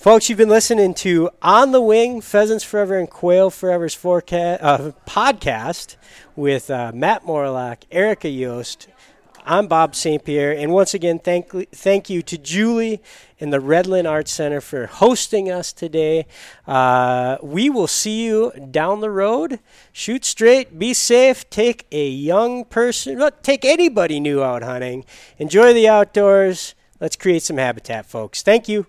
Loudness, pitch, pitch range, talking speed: -17 LUFS, 180 Hz, 145-220 Hz, 155 wpm